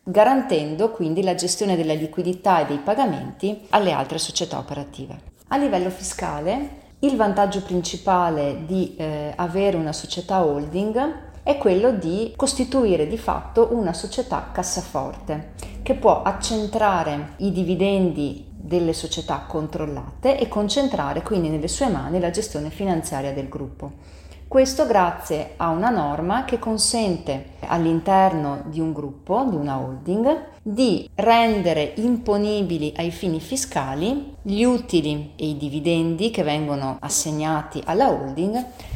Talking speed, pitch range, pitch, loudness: 125 wpm, 155-220 Hz, 180 Hz, -22 LUFS